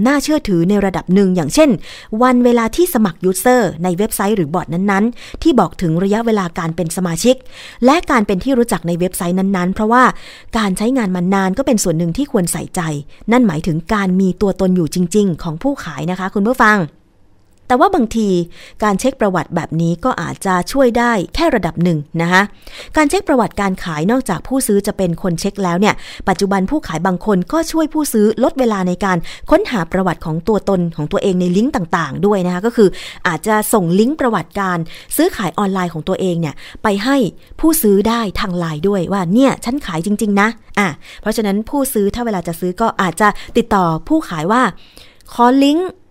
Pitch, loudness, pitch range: 200 Hz, -15 LUFS, 180-235 Hz